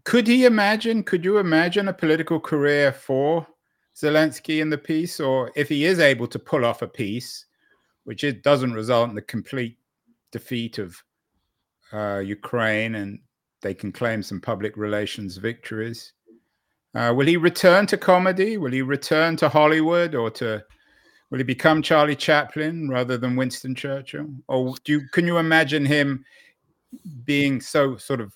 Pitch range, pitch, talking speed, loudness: 115-160 Hz, 140 Hz, 160 wpm, -21 LUFS